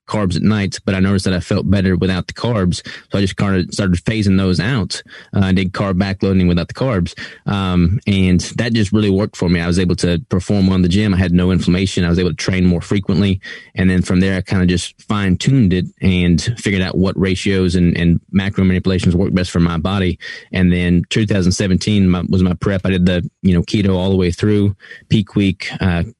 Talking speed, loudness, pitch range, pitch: 230 wpm, -16 LUFS, 90-100 Hz, 95 Hz